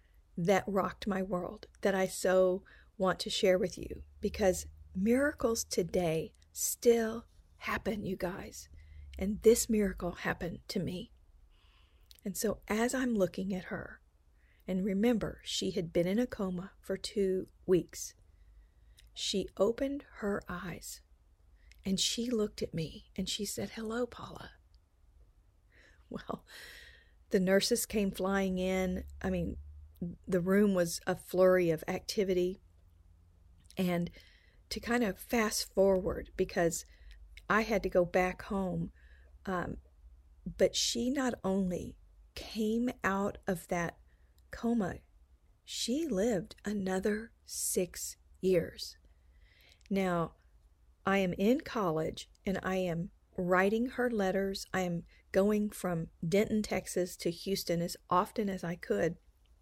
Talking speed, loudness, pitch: 125 wpm, -33 LUFS, 185 Hz